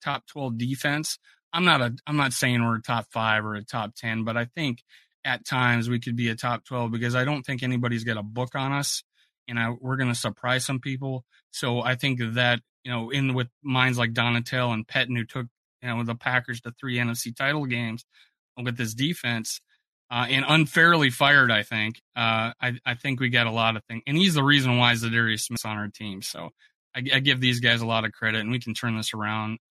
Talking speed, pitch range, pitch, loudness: 230 wpm, 115-130 Hz, 120 Hz, -25 LUFS